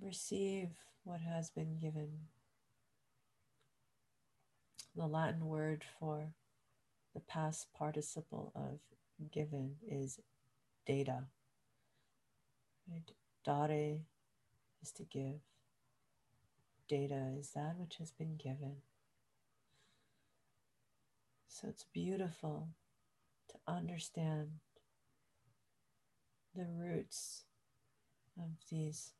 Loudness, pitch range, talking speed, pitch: -45 LUFS, 125-155 Hz, 75 wpm, 145 Hz